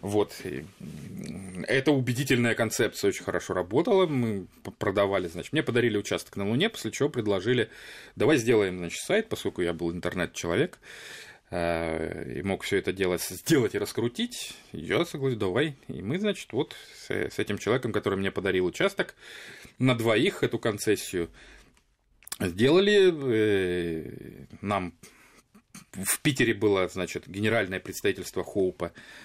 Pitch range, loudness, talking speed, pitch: 90-140 Hz, -27 LUFS, 125 wpm, 105 Hz